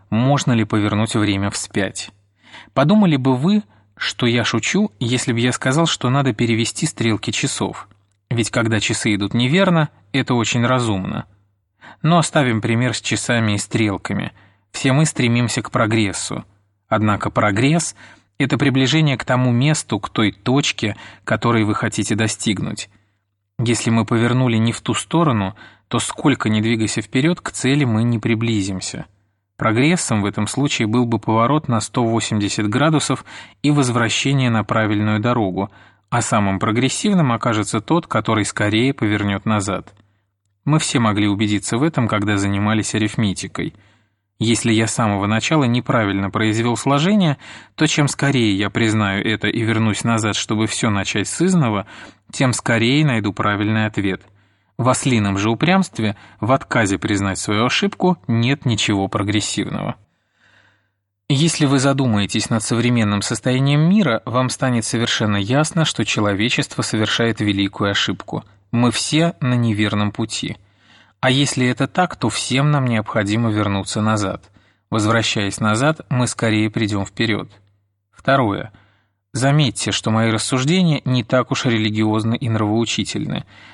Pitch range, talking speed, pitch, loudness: 105-130 Hz, 135 wpm, 115 Hz, -18 LUFS